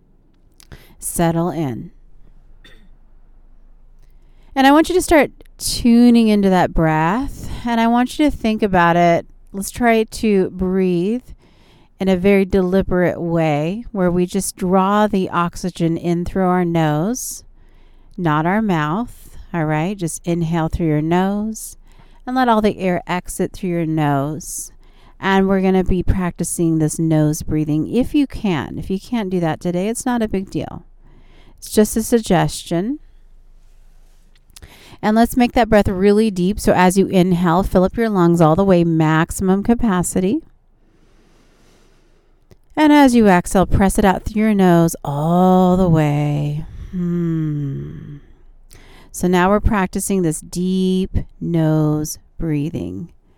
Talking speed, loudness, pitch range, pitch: 145 wpm, -17 LUFS, 165-210 Hz, 185 Hz